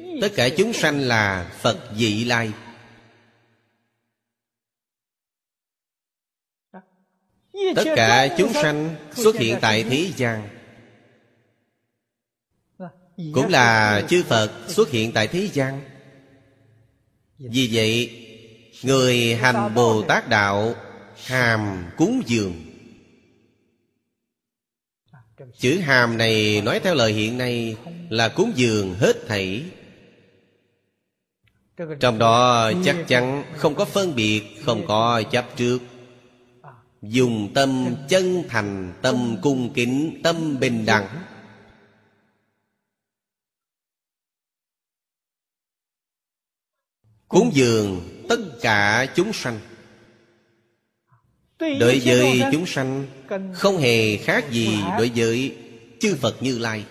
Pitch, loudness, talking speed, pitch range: 120 Hz, -20 LUFS, 95 wpm, 110-135 Hz